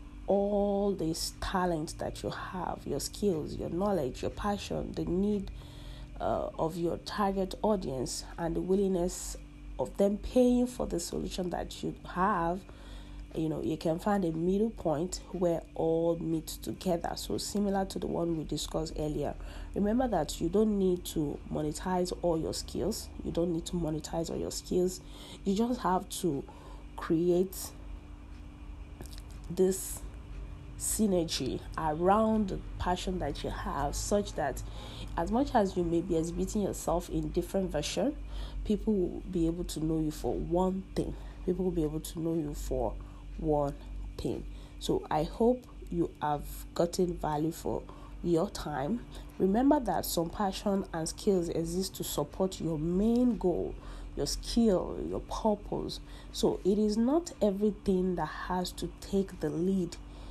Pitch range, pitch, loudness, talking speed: 160-200 Hz, 175 Hz, -32 LUFS, 150 wpm